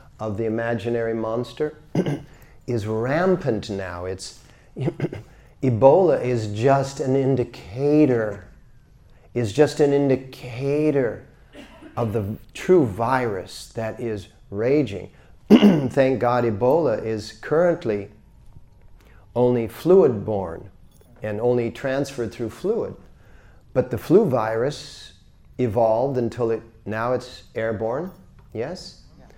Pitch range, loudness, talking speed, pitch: 110-135 Hz, -22 LUFS, 100 wpm, 120 Hz